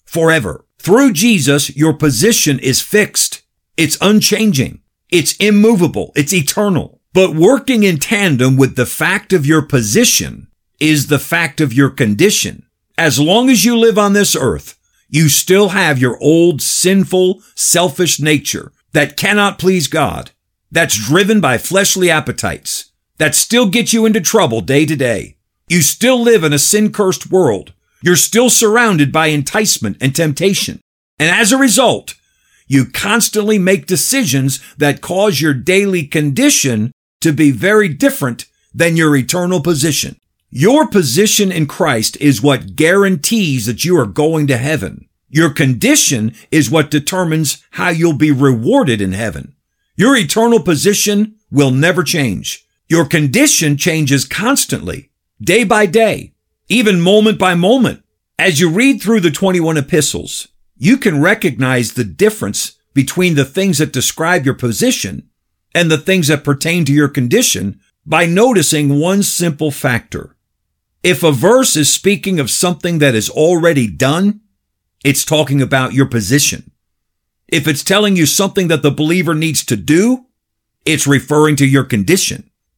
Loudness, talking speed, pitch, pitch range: -12 LUFS, 150 wpm, 165 Hz, 140-200 Hz